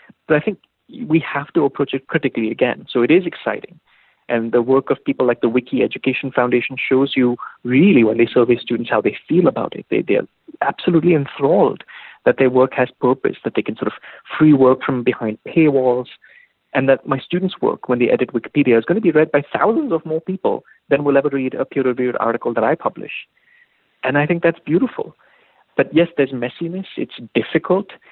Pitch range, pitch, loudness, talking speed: 125-160 Hz, 135 Hz, -18 LUFS, 205 wpm